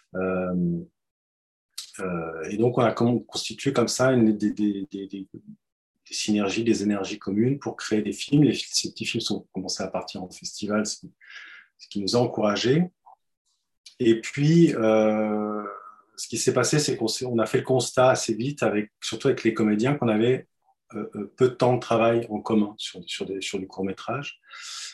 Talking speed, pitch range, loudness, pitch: 185 wpm, 100-125 Hz, -25 LUFS, 110 Hz